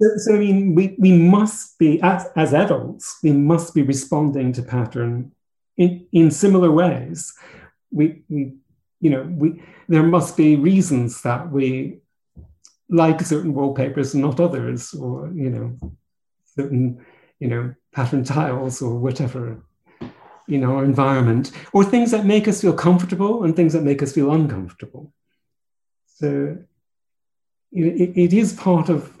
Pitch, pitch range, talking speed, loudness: 155 Hz, 135-175 Hz, 150 wpm, -18 LUFS